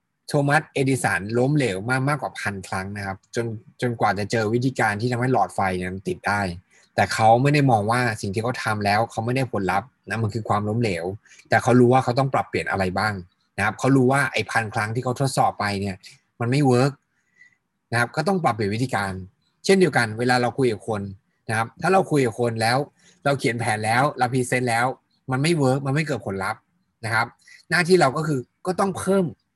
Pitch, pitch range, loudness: 125 Hz, 110-140 Hz, -22 LUFS